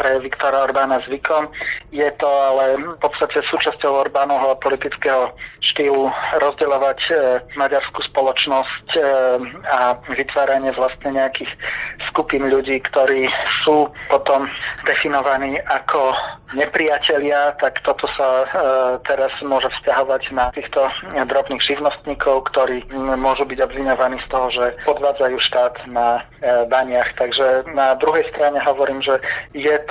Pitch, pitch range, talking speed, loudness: 135 Hz, 130-140 Hz, 125 wpm, -18 LUFS